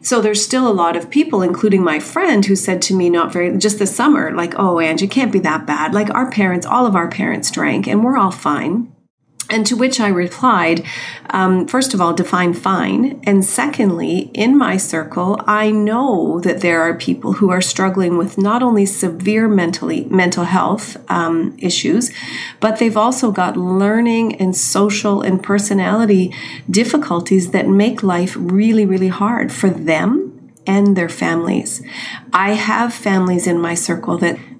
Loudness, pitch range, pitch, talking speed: -15 LUFS, 180-220 Hz, 195 Hz, 175 wpm